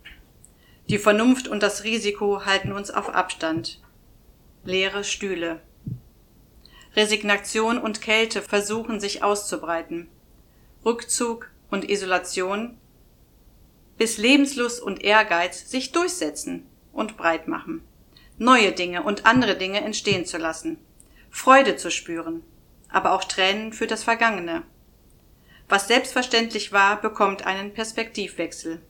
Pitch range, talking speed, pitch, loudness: 185-225 Hz, 110 wpm, 205 Hz, -22 LUFS